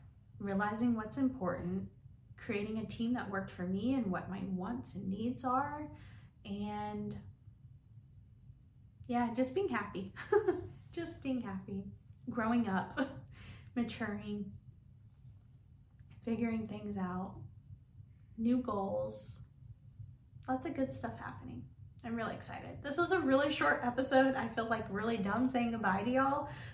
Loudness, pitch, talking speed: -37 LUFS, 200 Hz, 125 wpm